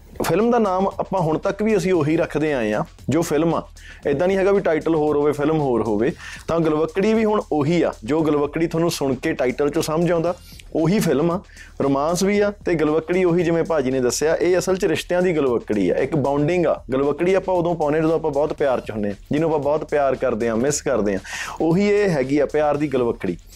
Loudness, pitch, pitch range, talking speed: -20 LUFS, 155 Hz, 140-175 Hz, 225 wpm